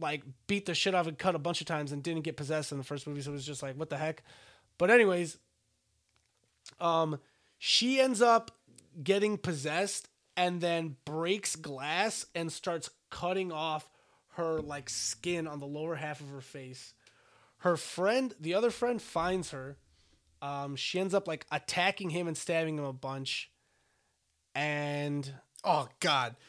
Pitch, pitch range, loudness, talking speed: 155 Hz, 140-175 Hz, -32 LUFS, 170 wpm